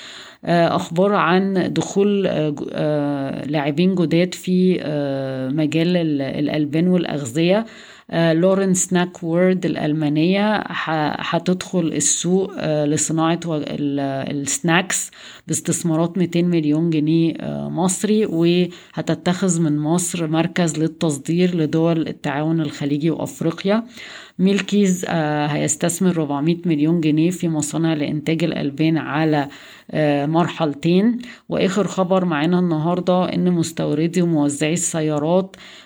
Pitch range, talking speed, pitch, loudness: 150-180 Hz, 85 wpm, 165 Hz, -19 LUFS